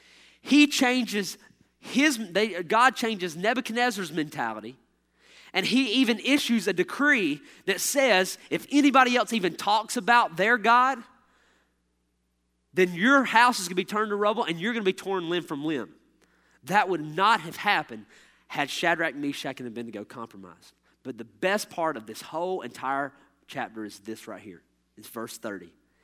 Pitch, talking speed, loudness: 190 Hz, 160 wpm, -25 LUFS